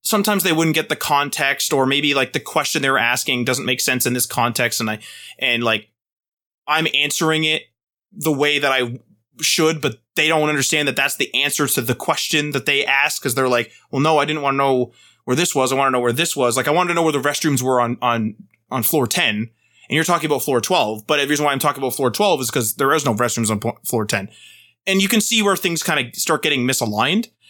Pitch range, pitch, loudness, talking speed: 120-155 Hz, 135 Hz, -18 LUFS, 250 wpm